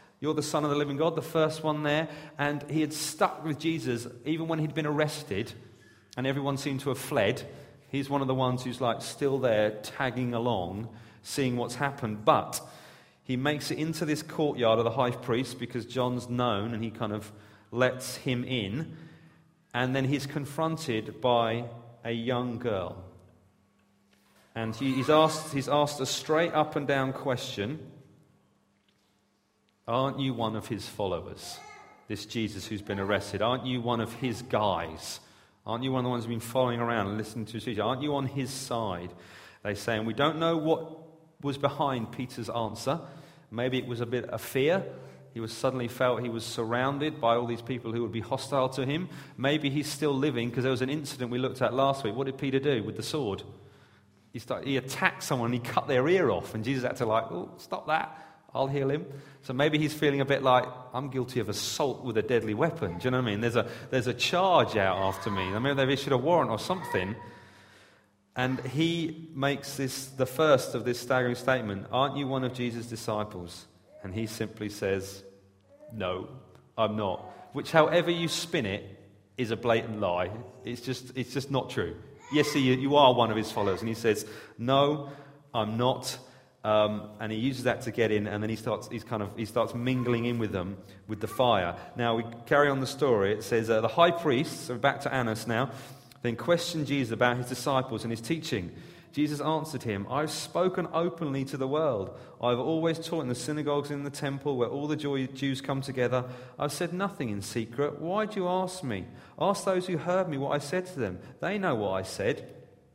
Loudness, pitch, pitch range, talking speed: -30 LUFS, 130 Hz, 115-145 Hz, 205 wpm